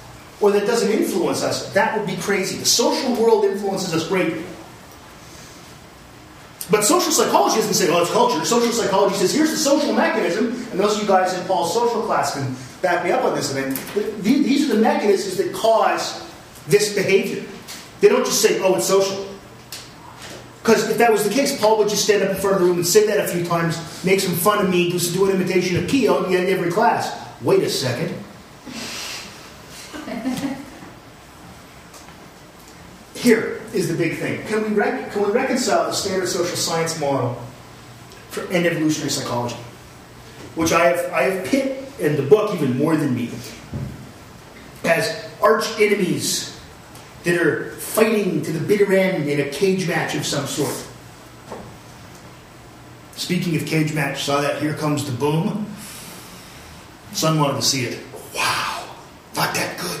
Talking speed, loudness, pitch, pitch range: 170 wpm, -19 LUFS, 185 Hz, 155-210 Hz